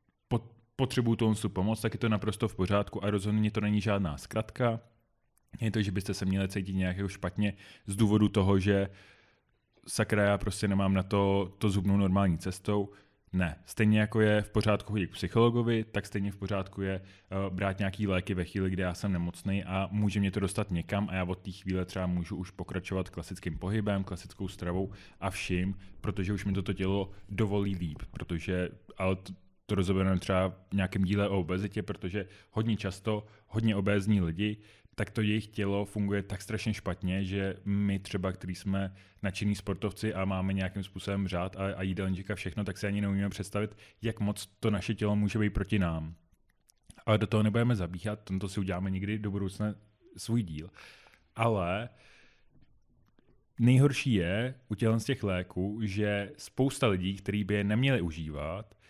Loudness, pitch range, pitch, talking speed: -32 LUFS, 95-105 Hz, 100 Hz, 175 wpm